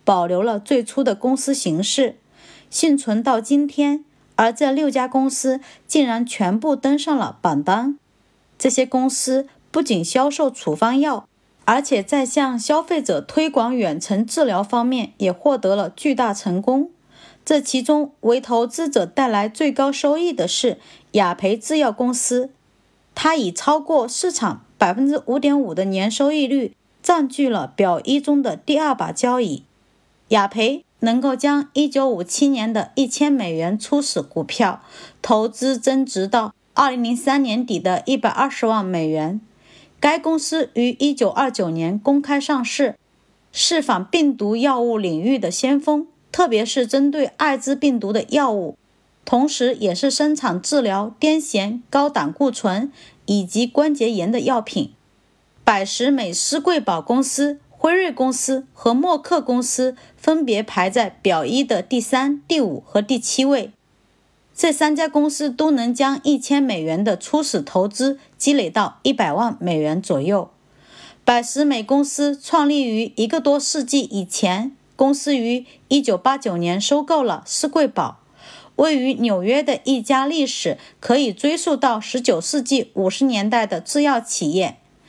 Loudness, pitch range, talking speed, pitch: -19 LUFS, 225-285 Hz, 215 characters per minute, 265 Hz